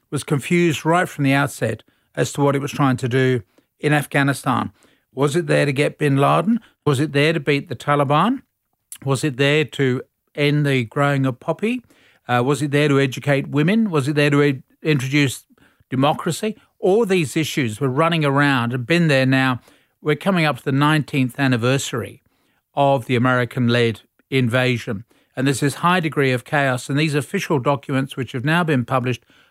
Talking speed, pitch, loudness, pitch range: 185 wpm, 140 Hz, -19 LUFS, 130-150 Hz